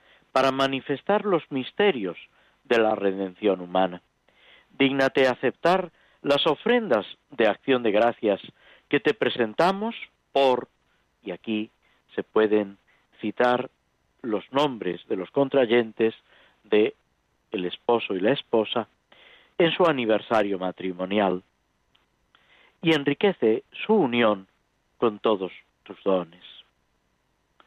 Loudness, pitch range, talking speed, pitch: -24 LUFS, 95-140 Hz, 105 wpm, 120 Hz